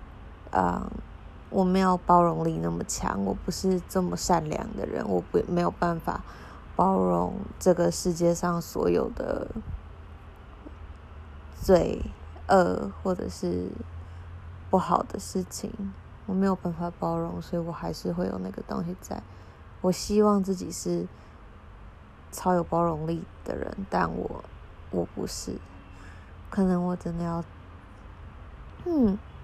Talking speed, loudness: 185 characters per minute, -28 LUFS